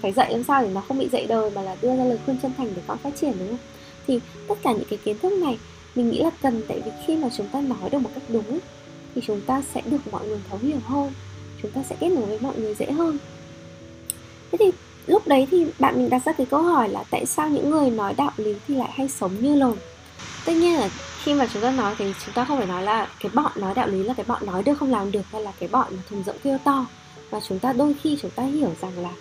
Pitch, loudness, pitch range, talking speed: 255 Hz, -24 LUFS, 210-285 Hz, 290 wpm